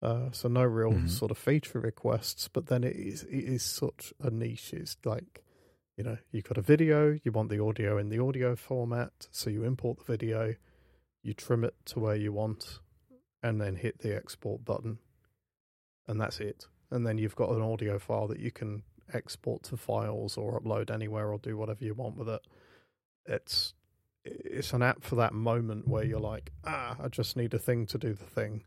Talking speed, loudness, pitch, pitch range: 205 wpm, -33 LUFS, 115 Hz, 105-125 Hz